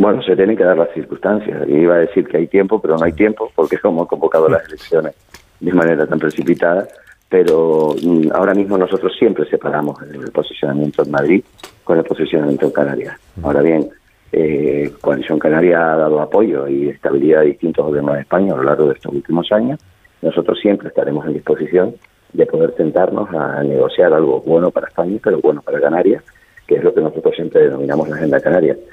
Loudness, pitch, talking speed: -15 LUFS, 100 Hz, 195 wpm